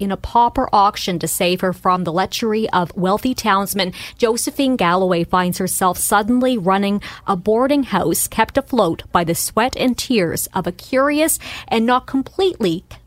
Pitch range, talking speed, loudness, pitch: 185-250 Hz, 160 wpm, -18 LUFS, 200 Hz